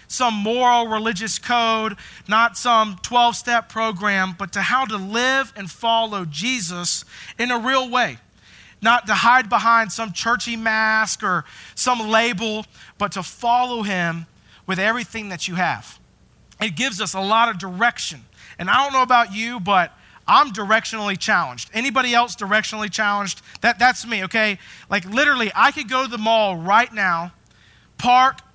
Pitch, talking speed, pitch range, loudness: 225 Hz, 160 wpm, 200-240 Hz, -19 LUFS